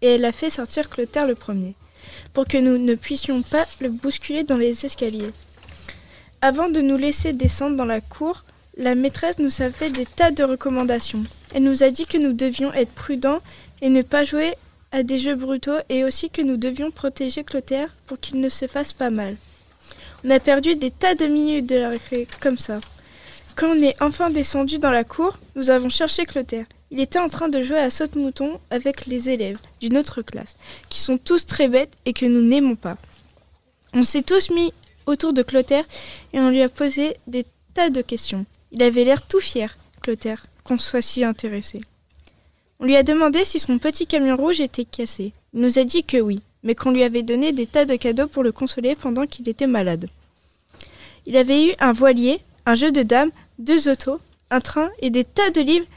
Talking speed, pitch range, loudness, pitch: 205 wpm, 245-290 Hz, -20 LUFS, 265 Hz